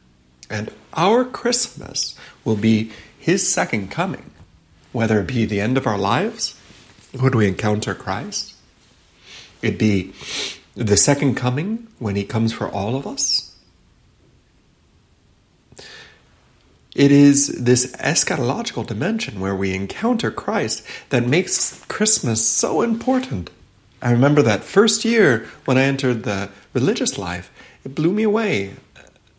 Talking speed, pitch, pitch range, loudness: 125 wpm, 110 Hz, 95-140 Hz, -18 LUFS